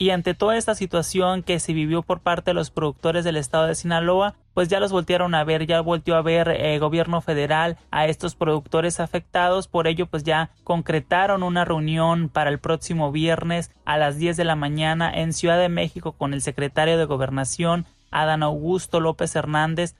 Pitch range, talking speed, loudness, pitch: 155-175 Hz, 190 wpm, -22 LUFS, 165 Hz